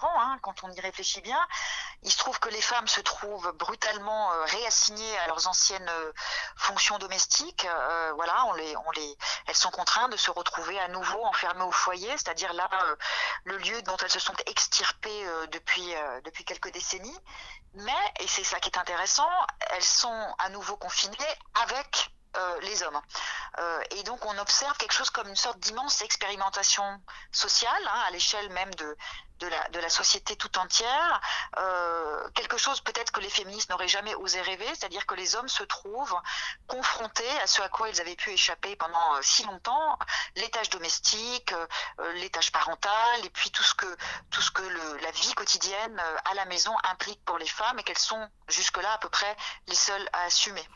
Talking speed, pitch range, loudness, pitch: 185 wpm, 175-215 Hz, -28 LUFS, 195 Hz